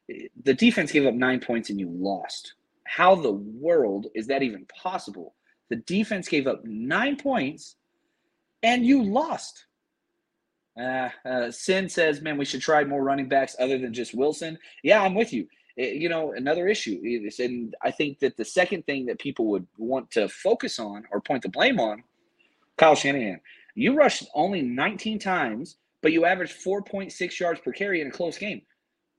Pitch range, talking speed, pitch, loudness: 130-215 Hz, 180 wpm, 165 Hz, -25 LUFS